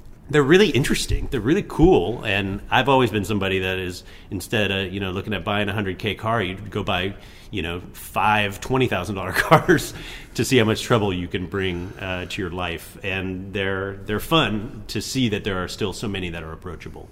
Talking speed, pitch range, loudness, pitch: 210 wpm, 95-110 Hz, -22 LUFS, 100 Hz